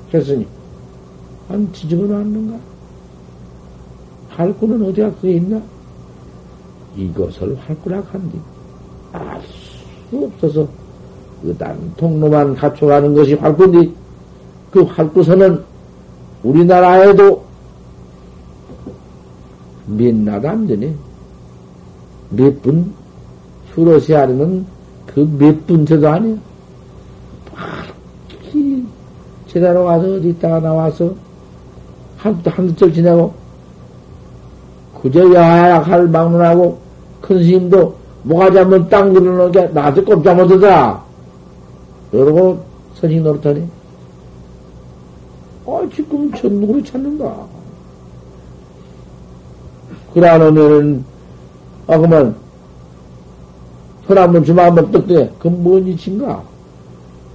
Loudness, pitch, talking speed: -12 LUFS, 145 Hz, 185 characters per minute